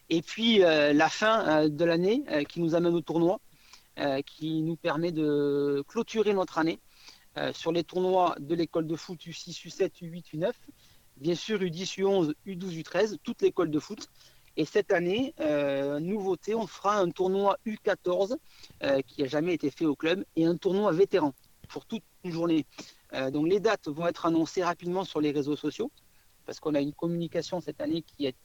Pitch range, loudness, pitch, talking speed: 155-190 Hz, -29 LUFS, 170 Hz, 190 wpm